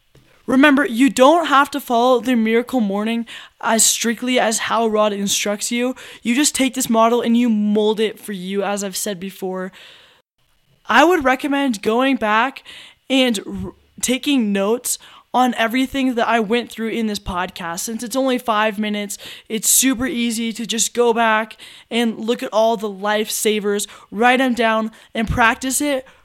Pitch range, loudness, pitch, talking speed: 215-260 Hz, -18 LUFS, 230 Hz, 165 wpm